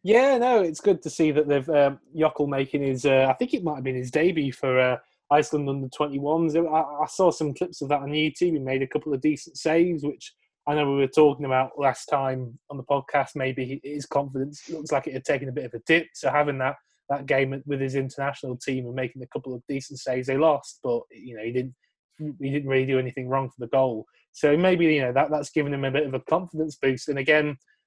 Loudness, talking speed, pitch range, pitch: -25 LUFS, 250 wpm, 135-155 Hz, 145 Hz